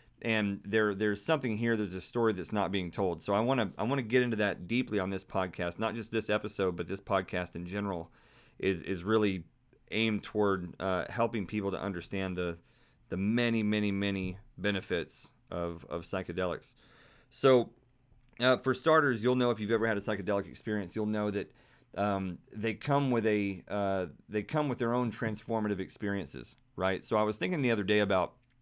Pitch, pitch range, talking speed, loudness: 105 Hz, 95-115 Hz, 195 wpm, -32 LUFS